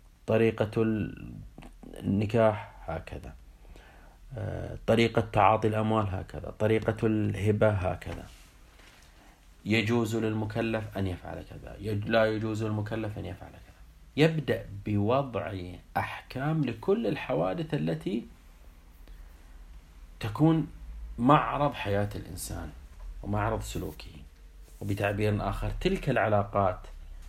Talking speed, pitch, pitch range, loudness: 80 wpm, 100 Hz, 80-110 Hz, -29 LUFS